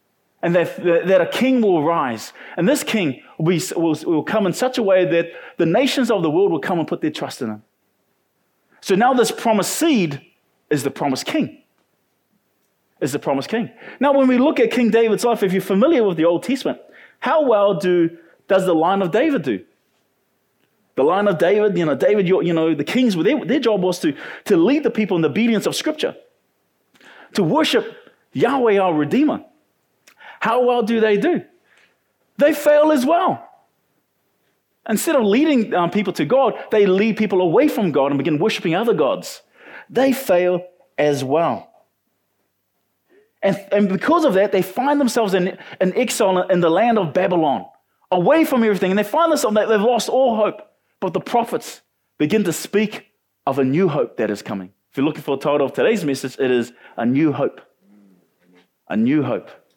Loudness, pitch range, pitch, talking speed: -18 LUFS, 170-245 Hz, 205 Hz, 190 wpm